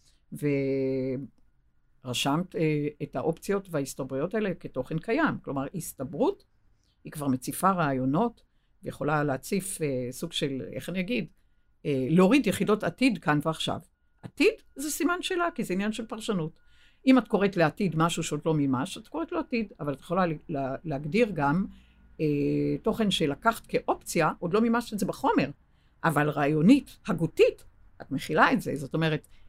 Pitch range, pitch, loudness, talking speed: 145-215 Hz, 160 Hz, -28 LUFS, 150 wpm